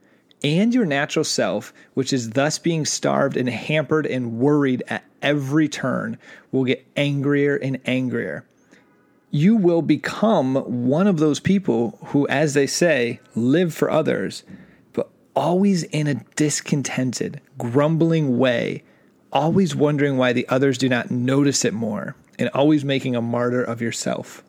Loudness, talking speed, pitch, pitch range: -21 LUFS, 145 wpm, 140 Hz, 130-155 Hz